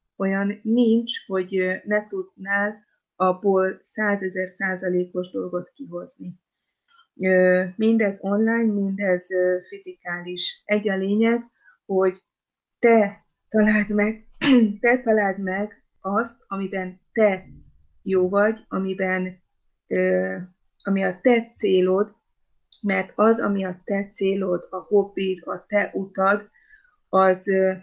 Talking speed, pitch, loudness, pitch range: 100 wpm, 195 Hz, -23 LUFS, 185-215 Hz